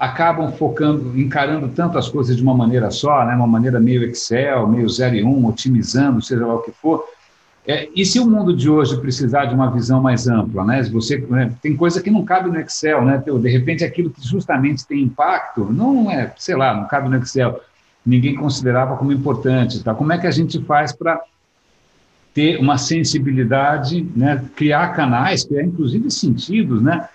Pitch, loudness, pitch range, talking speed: 135 Hz, -17 LUFS, 125-155 Hz, 190 wpm